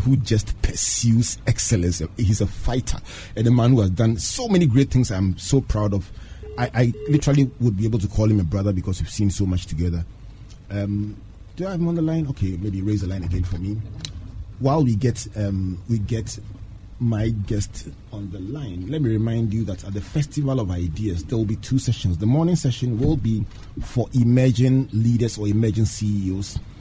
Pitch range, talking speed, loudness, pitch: 100-125 Hz, 205 wpm, -22 LUFS, 110 Hz